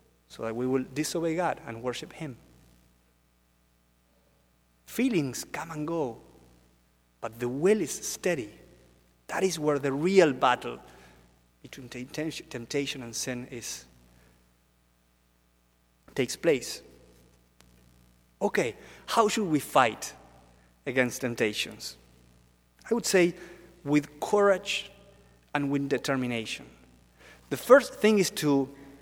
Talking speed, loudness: 105 wpm, -28 LUFS